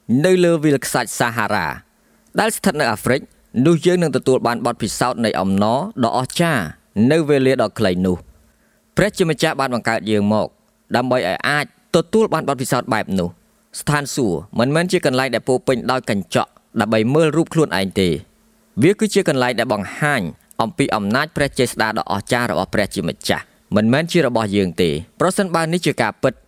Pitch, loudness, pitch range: 130 Hz, -18 LUFS, 115-165 Hz